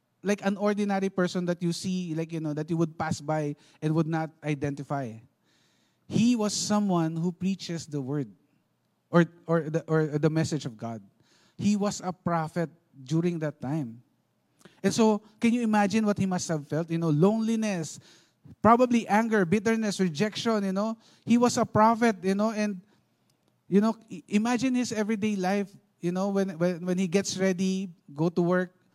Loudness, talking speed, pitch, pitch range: -27 LUFS, 175 wpm, 180 Hz, 160-210 Hz